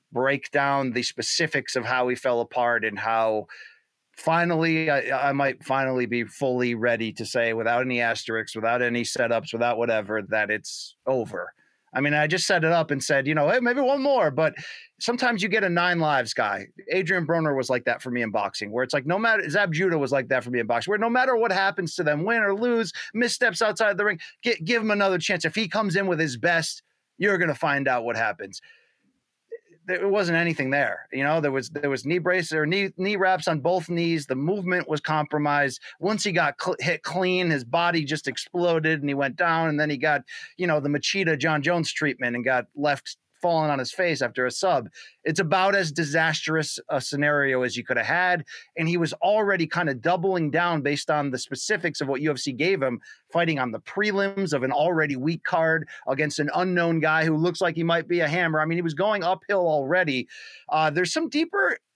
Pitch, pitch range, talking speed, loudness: 160 Hz, 135-185 Hz, 220 wpm, -24 LUFS